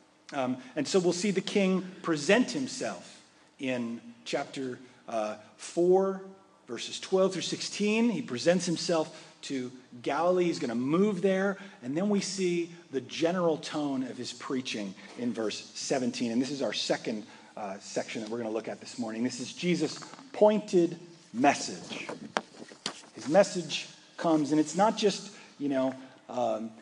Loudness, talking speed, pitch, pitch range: -30 LUFS, 155 wpm, 165 Hz, 130-195 Hz